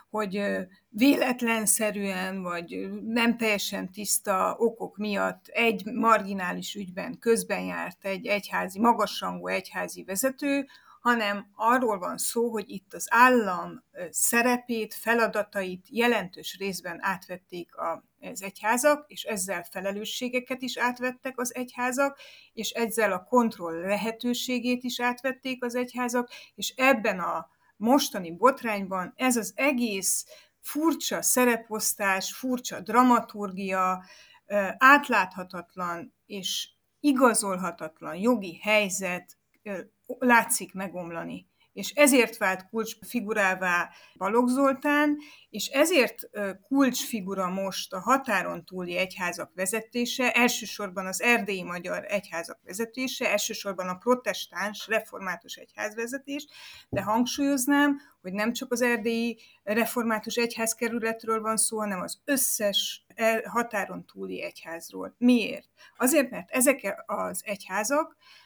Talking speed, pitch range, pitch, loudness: 105 wpm, 195-245 Hz, 220 Hz, -27 LUFS